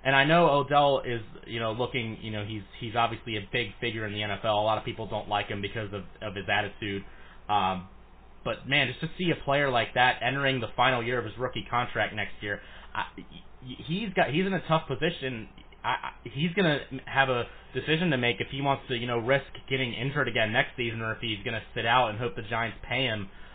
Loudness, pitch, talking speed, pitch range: -28 LUFS, 120 Hz, 240 wpm, 110-135 Hz